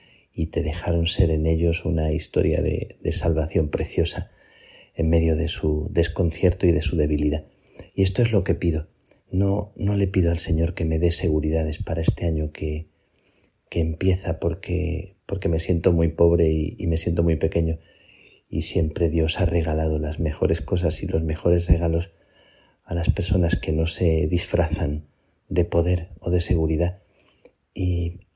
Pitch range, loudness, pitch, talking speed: 80-90 Hz, -23 LUFS, 85 Hz, 170 wpm